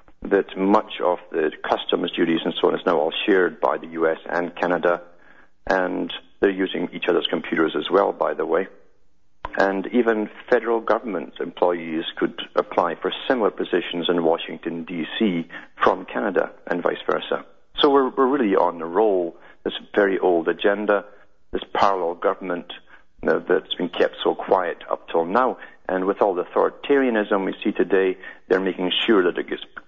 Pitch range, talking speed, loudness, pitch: 85-110 Hz, 170 wpm, -22 LUFS, 95 Hz